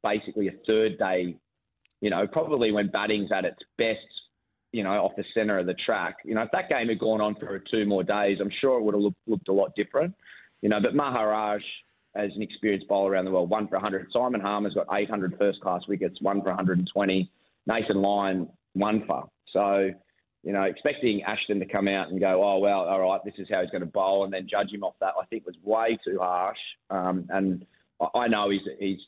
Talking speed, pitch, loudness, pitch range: 225 wpm, 100 Hz, -27 LUFS, 95-105 Hz